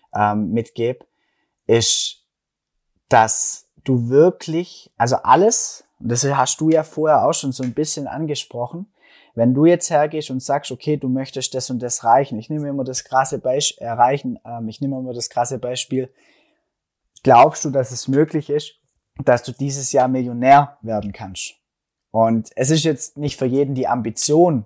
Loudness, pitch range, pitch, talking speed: -18 LUFS, 120-145 Hz, 130 Hz, 165 wpm